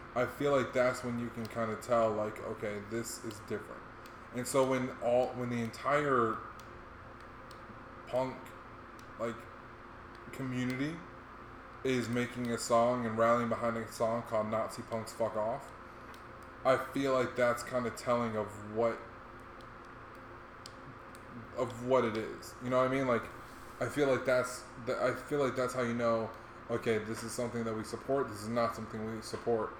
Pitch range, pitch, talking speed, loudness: 110-125 Hz, 115 Hz, 165 wpm, -34 LUFS